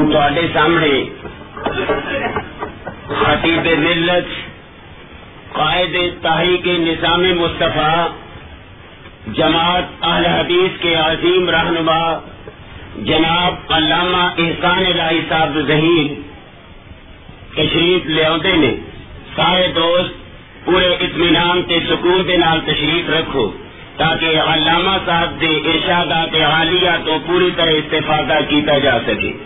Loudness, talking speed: -14 LUFS, 100 wpm